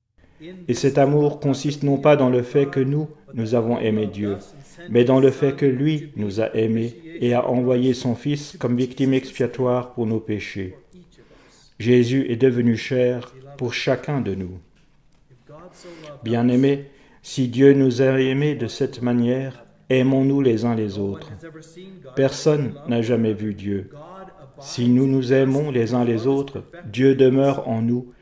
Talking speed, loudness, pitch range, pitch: 155 wpm, -20 LUFS, 120-140 Hz, 130 Hz